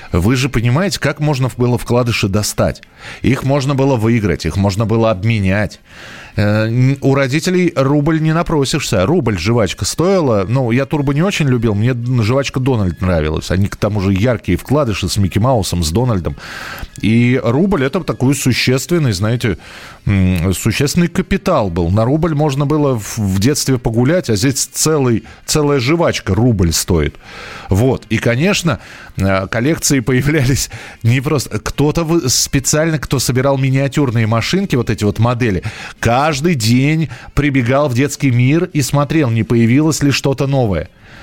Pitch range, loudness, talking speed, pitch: 110-145 Hz, -14 LUFS, 145 wpm, 125 Hz